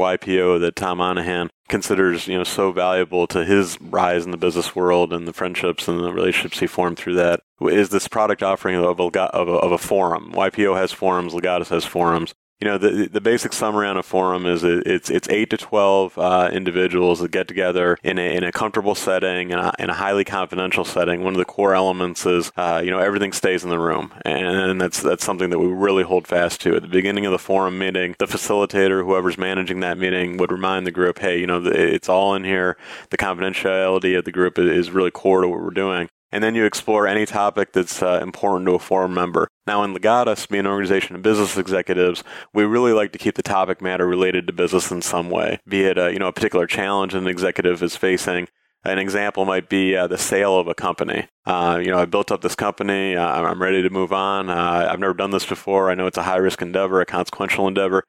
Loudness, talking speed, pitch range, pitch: -20 LUFS, 230 wpm, 90-95 Hz, 95 Hz